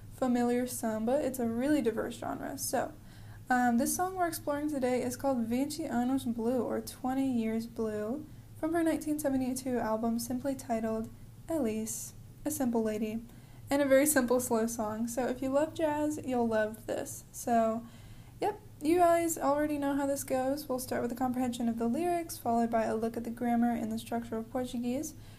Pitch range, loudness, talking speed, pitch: 230-280 Hz, -32 LUFS, 180 wpm, 250 Hz